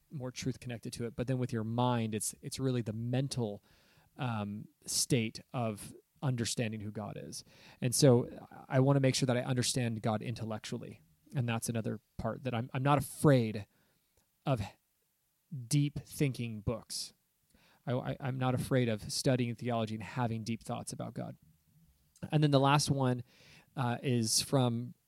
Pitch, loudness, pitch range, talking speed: 125 Hz, -33 LUFS, 115-135 Hz, 165 wpm